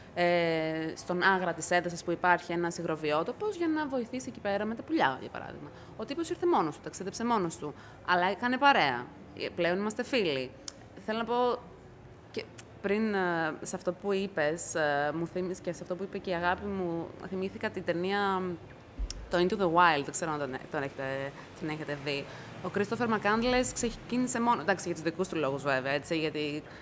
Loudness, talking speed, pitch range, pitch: -31 LUFS, 190 wpm, 155-205 Hz, 180 Hz